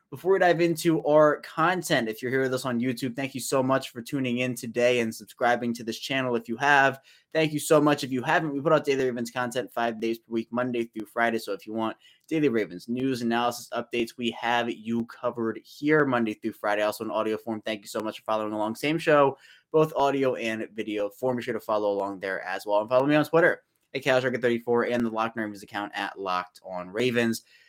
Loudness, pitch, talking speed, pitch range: -26 LUFS, 120 Hz, 230 wpm, 110-135 Hz